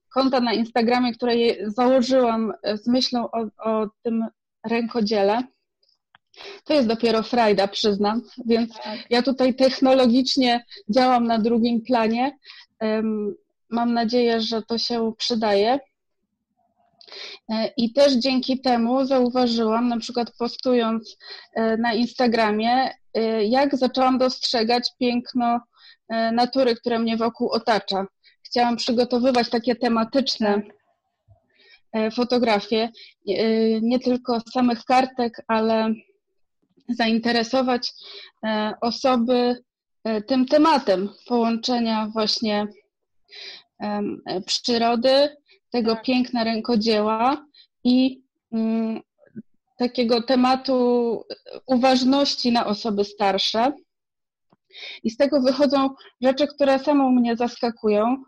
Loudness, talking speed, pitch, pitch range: -21 LUFS, 90 wpm, 240 Hz, 225-260 Hz